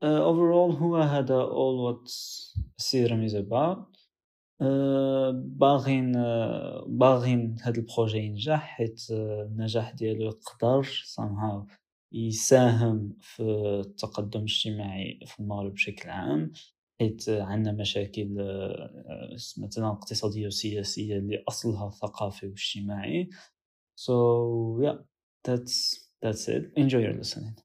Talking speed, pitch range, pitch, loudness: 100 wpm, 105-130 Hz, 115 Hz, -28 LUFS